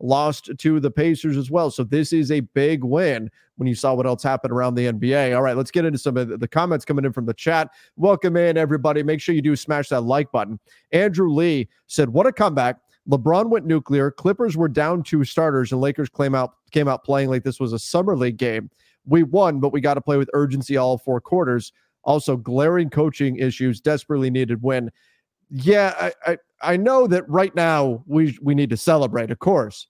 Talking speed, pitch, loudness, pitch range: 215 wpm, 145 Hz, -20 LUFS, 130-160 Hz